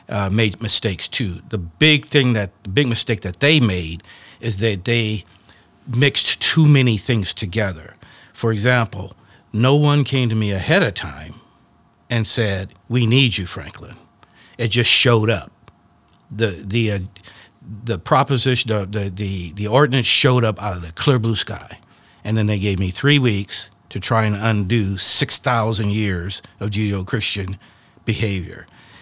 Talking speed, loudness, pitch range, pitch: 155 wpm, -18 LUFS, 100-120 Hz, 110 Hz